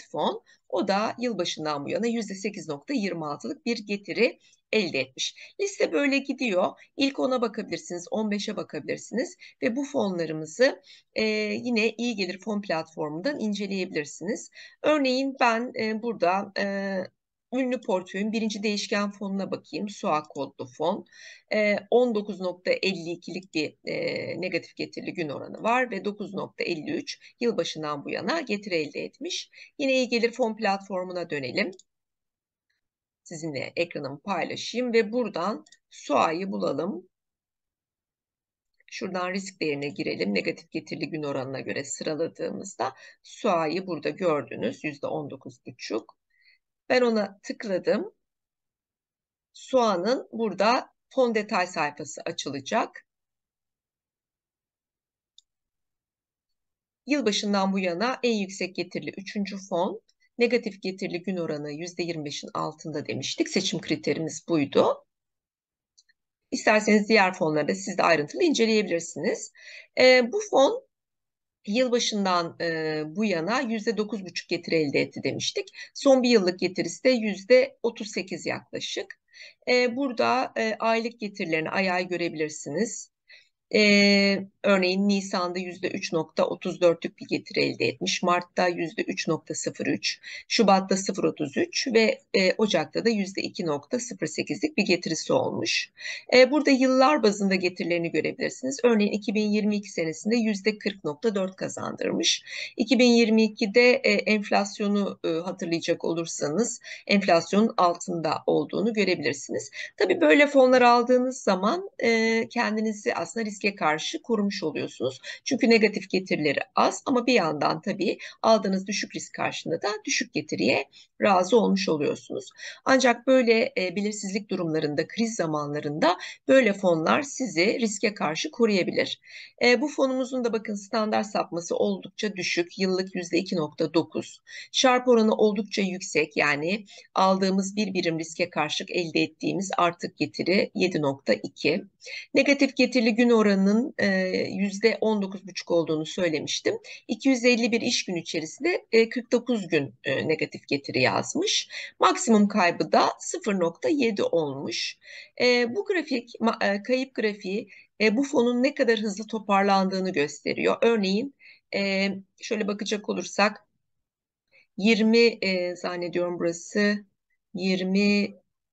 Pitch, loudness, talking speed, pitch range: 210 Hz, -25 LUFS, 110 wpm, 175-245 Hz